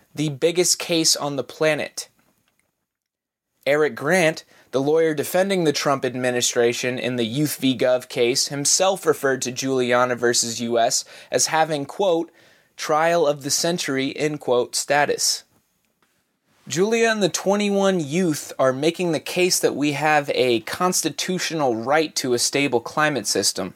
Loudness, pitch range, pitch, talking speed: -21 LUFS, 125-170 Hz, 150 Hz, 140 wpm